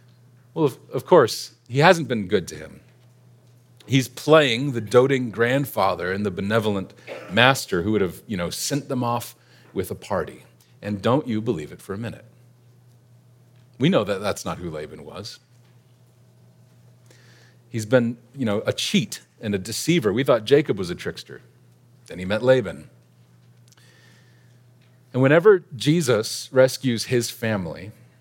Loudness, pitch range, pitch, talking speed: -22 LUFS, 120-125 Hz, 125 Hz, 150 wpm